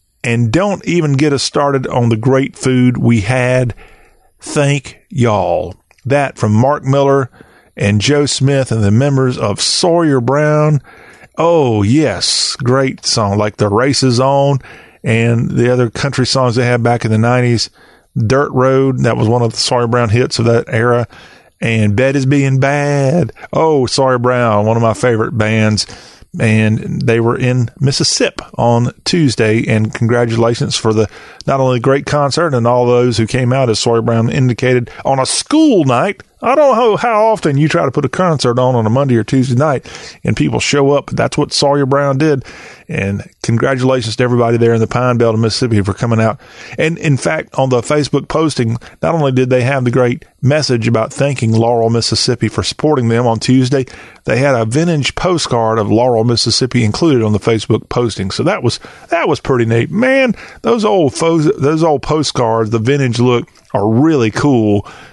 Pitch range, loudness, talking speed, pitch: 115-140 Hz, -13 LUFS, 185 wpm, 125 Hz